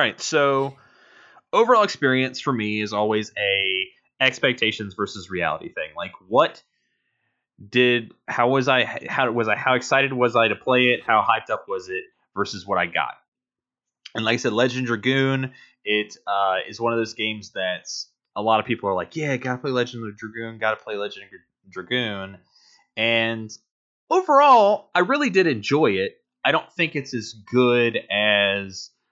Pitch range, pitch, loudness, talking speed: 110-135 Hz, 120 Hz, -21 LUFS, 175 wpm